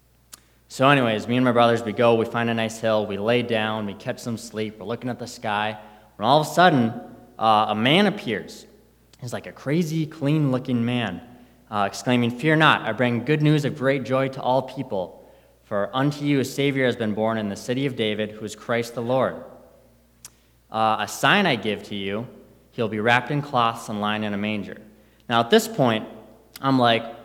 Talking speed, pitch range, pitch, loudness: 210 wpm, 110-130 Hz, 120 Hz, -22 LUFS